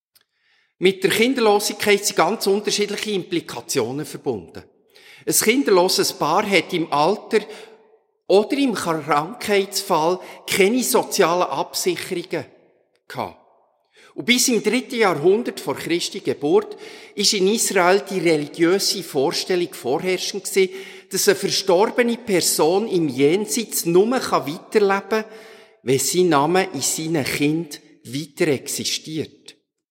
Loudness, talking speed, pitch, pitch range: -20 LUFS, 110 wpm, 195 Hz, 175-225 Hz